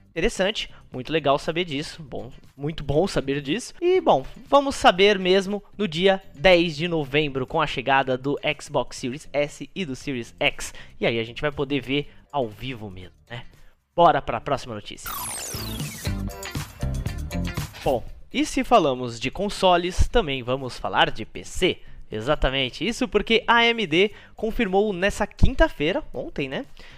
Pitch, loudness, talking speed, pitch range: 150 Hz, -23 LUFS, 150 wpm, 130-200 Hz